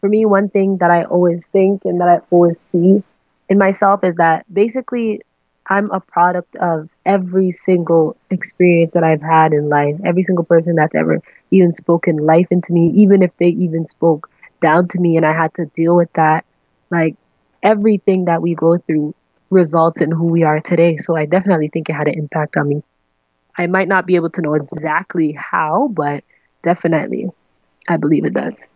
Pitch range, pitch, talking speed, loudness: 160-185 Hz, 170 Hz, 190 wpm, -15 LUFS